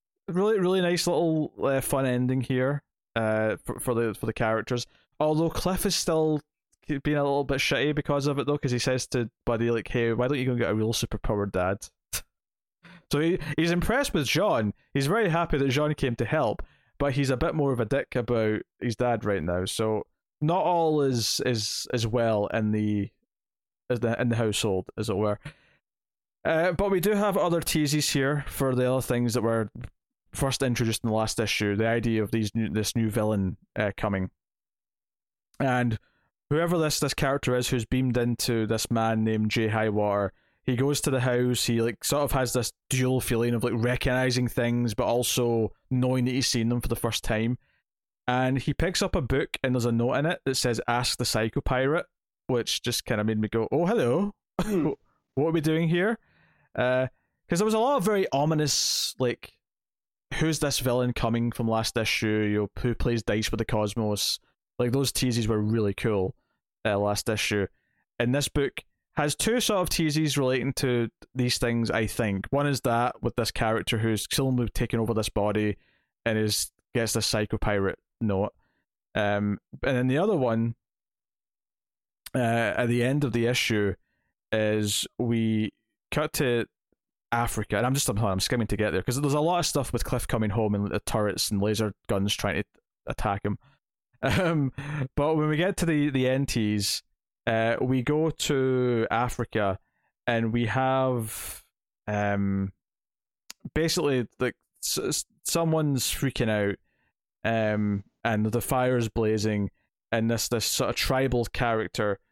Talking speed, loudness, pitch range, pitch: 185 wpm, -27 LUFS, 110-140 Hz, 120 Hz